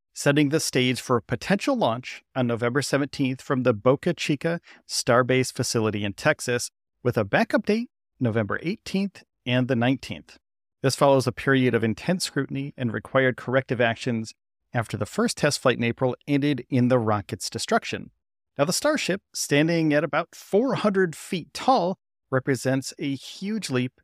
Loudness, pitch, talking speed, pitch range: -24 LUFS, 135 Hz, 155 wpm, 125-165 Hz